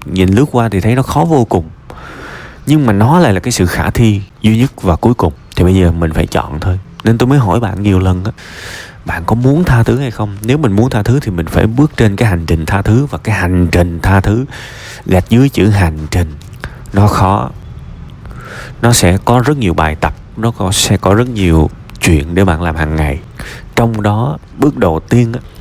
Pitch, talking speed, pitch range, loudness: 105 Hz, 230 wpm, 90-120 Hz, -12 LUFS